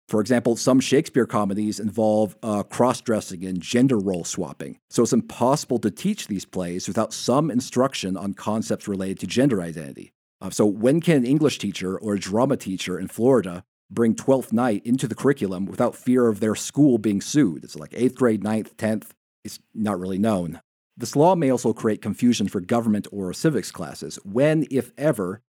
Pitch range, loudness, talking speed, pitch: 100-130 Hz, -23 LUFS, 185 wpm, 110 Hz